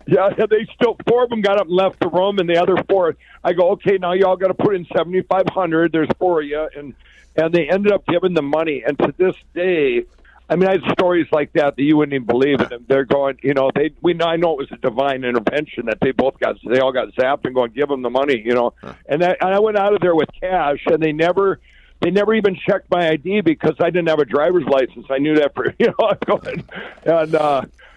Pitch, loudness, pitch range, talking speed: 170 Hz, -17 LUFS, 145-190 Hz, 270 wpm